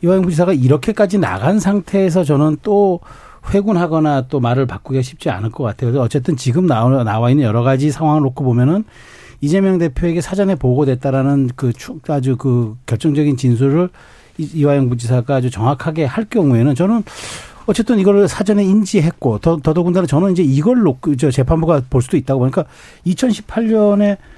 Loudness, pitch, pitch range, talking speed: -15 LUFS, 150 Hz, 135-190 Hz, 375 characters per minute